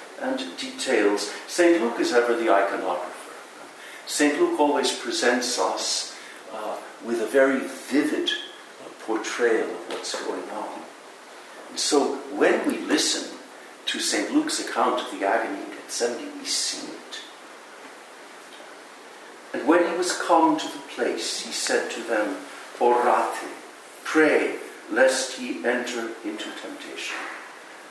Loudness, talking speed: -24 LUFS, 130 wpm